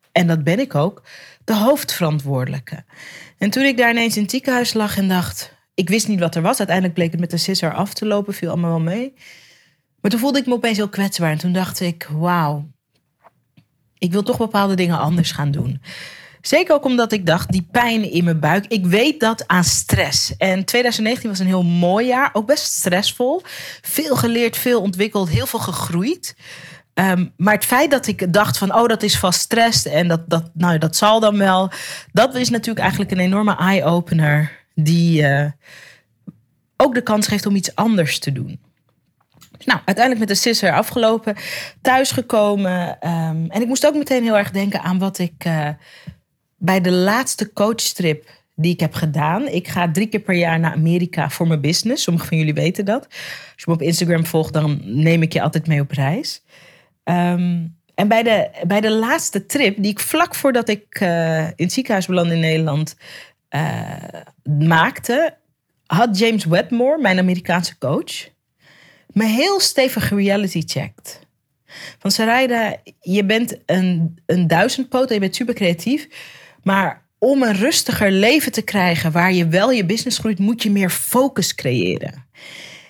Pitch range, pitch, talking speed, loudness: 165-225 Hz, 190 Hz, 180 wpm, -17 LUFS